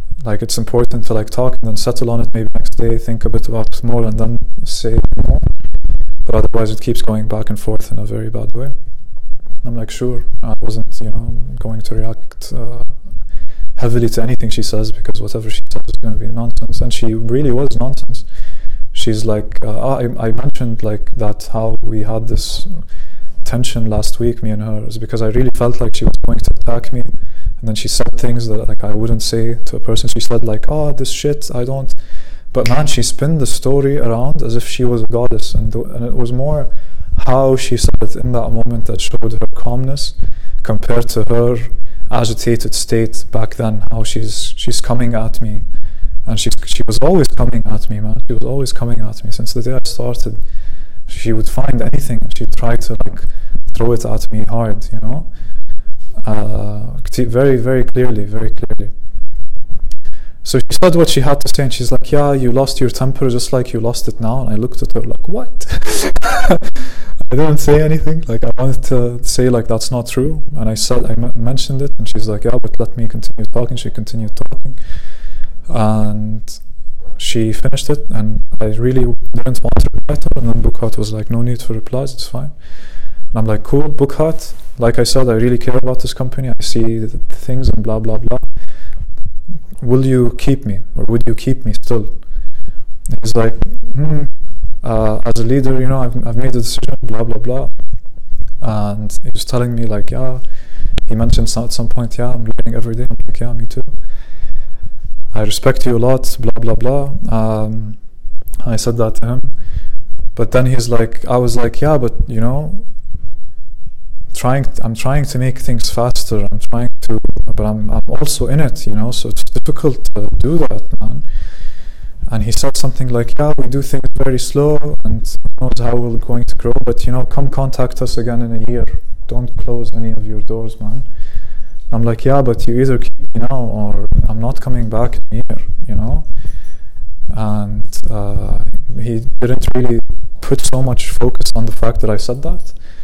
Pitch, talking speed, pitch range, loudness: 115 Hz, 205 wpm, 105-125 Hz, -18 LUFS